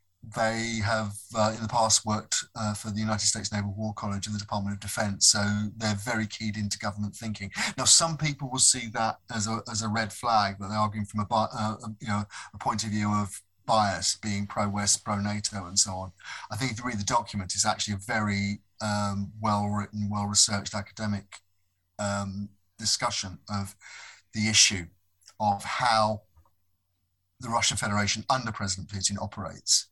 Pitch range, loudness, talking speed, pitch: 100-110 Hz, -27 LUFS, 185 wpm, 105 Hz